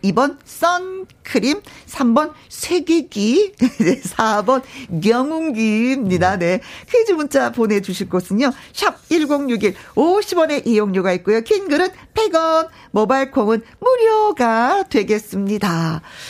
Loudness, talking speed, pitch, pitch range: -18 LUFS, 200 characters per minute, 260 Hz, 210-330 Hz